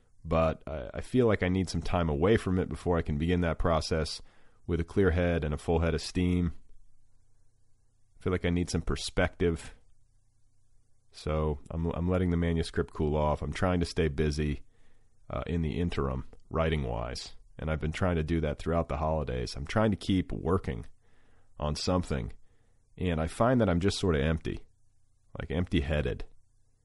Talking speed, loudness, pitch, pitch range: 185 wpm, -30 LUFS, 85 Hz, 80-100 Hz